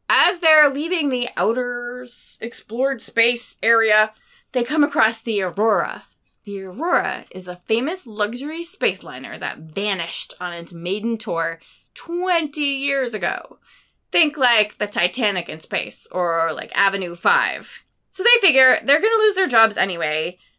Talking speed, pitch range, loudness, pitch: 145 wpm, 195-290 Hz, -20 LUFS, 230 Hz